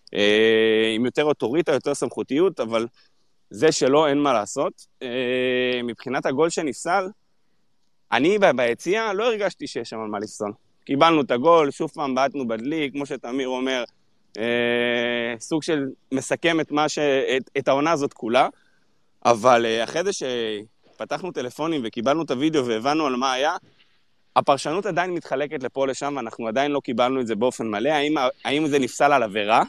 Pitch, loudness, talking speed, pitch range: 130 Hz, -22 LUFS, 150 wpm, 120-150 Hz